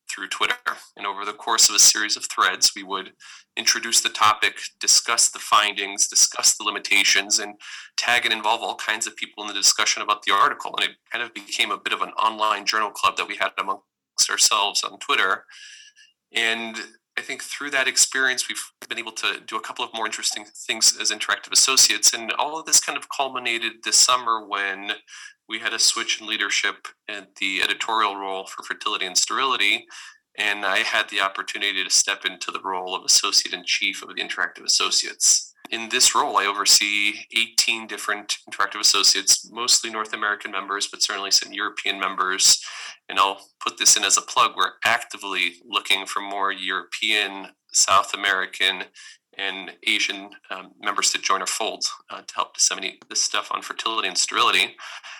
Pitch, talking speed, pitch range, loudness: 105 Hz, 185 wpm, 100-115 Hz, -20 LUFS